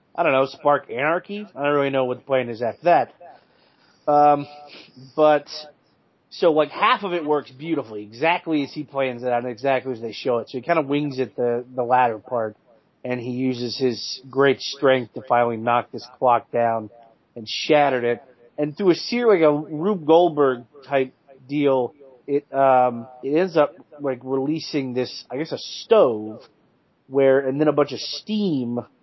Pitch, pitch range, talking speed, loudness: 135 Hz, 125-150 Hz, 185 wpm, -21 LUFS